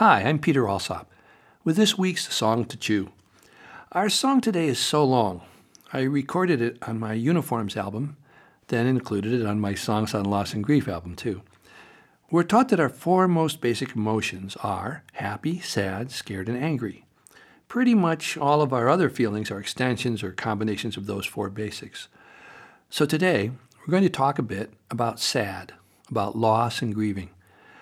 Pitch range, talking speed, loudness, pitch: 105-155 Hz, 170 wpm, -25 LUFS, 120 Hz